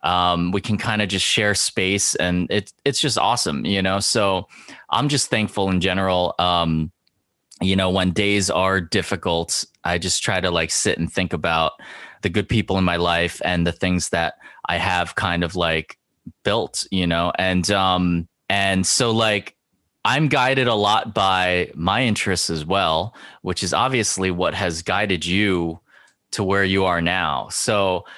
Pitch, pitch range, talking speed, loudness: 95 Hz, 85-100 Hz, 175 wpm, -20 LUFS